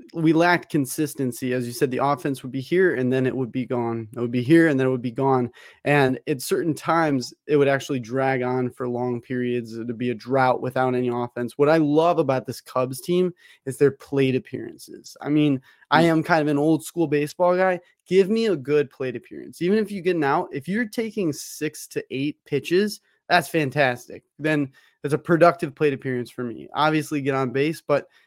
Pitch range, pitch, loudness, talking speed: 130-160 Hz, 140 Hz, -23 LUFS, 215 wpm